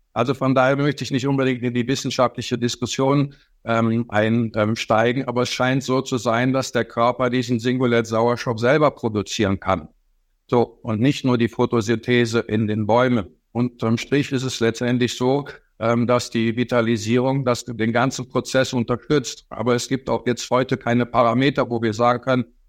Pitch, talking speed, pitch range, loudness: 120 Hz, 170 wpm, 115-130 Hz, -21 LUFS